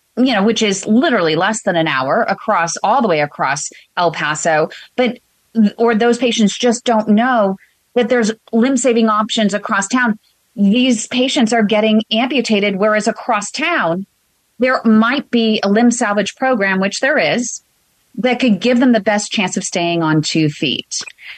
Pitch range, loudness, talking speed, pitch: 195-245 Hz, -15 LUFS, 170 wpm, 220 Hz